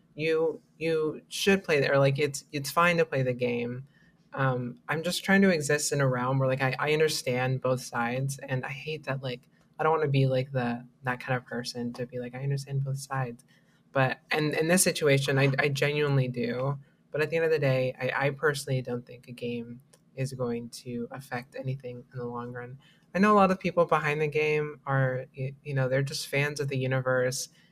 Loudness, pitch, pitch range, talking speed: -28 LUFS, 135 Hz, 125-150 Hz, 220 wpm